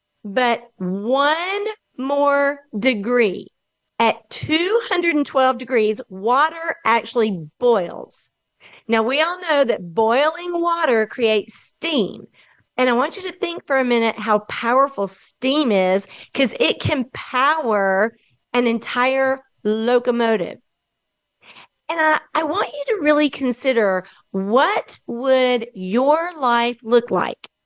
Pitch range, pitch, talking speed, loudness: 225-295 Hz, 250 Hz, 115 wpm, -19 LUFS